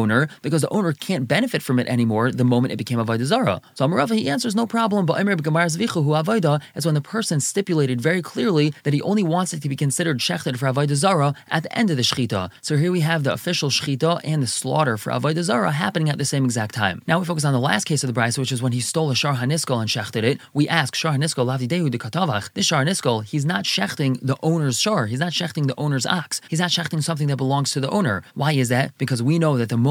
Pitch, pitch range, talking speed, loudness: 150 Hz, 130-165 Hz, 250 wpm, -21 LUFS